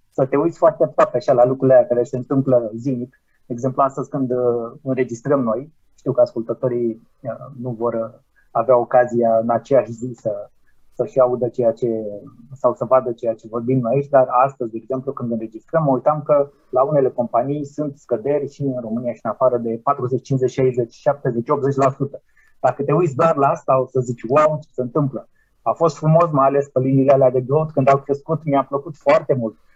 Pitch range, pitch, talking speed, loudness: 120-140 Hz, 130 Hz, 200 wpm, -19 LUFS